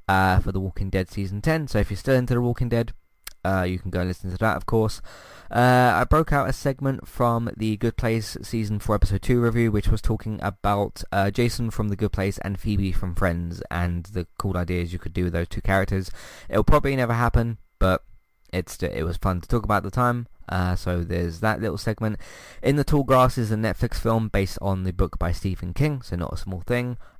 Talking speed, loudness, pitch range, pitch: 235 wpm, -24 LUFS, 95-120 Hz, 105 Hz